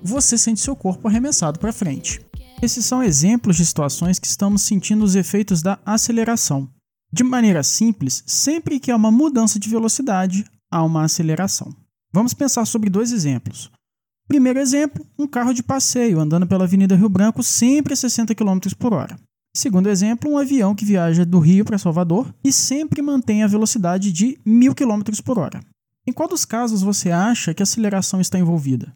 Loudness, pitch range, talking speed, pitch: -18 LUFS, 185-240 Hz, 175 wpm, 210 Hz